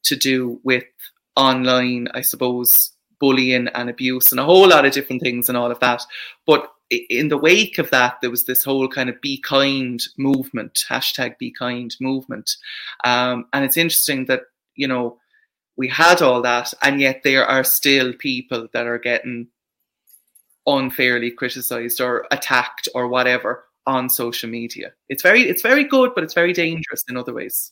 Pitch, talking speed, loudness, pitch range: 130 Hz, 175 wpm, -17 LUFS, 125-140 Hz